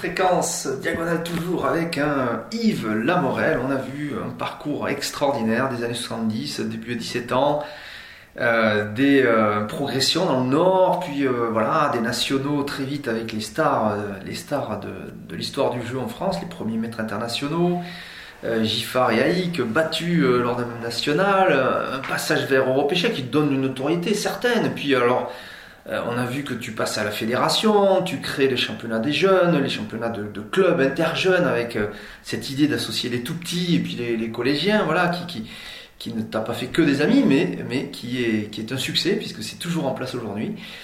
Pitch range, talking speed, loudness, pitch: 115-170 Hz, 185 wpm, -22 LUFS, 135 Hz